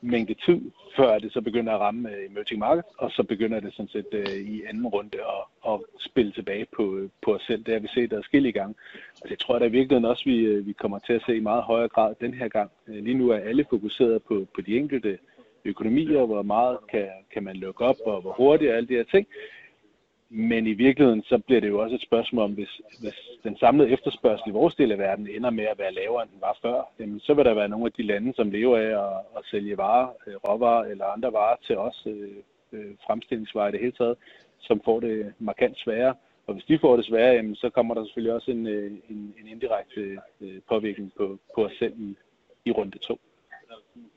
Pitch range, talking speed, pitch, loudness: 105-120 Hz, 230 wpm, 115 Hz, -25 LUFS